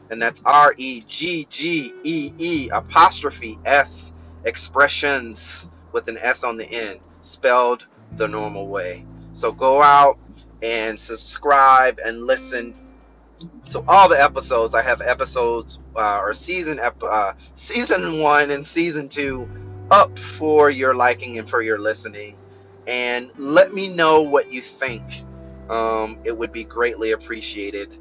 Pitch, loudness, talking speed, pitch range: 115 Hz, -18 LUFS, 130 wpm, 100-140 Hz